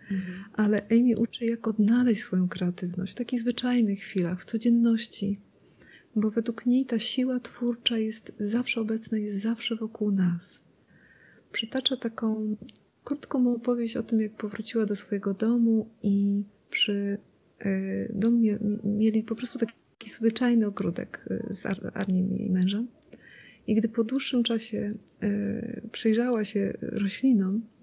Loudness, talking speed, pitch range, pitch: -28 LUFS, 135 wpm, 205-235 Hz, 220 Hz